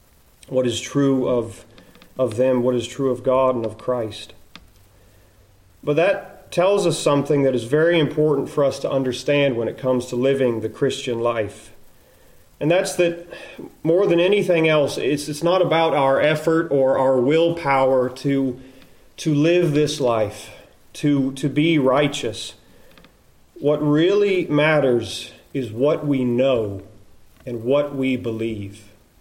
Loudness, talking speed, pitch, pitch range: -20 LUFS, 145 wpm, 135 Hz, 120-150 Hz